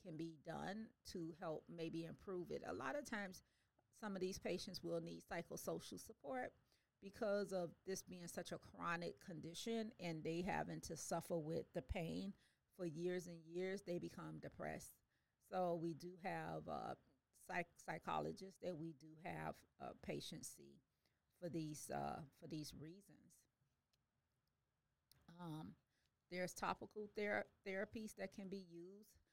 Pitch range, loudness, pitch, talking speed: 165-195 Hz, -50 LUFS, 175 Hz, 145 wpm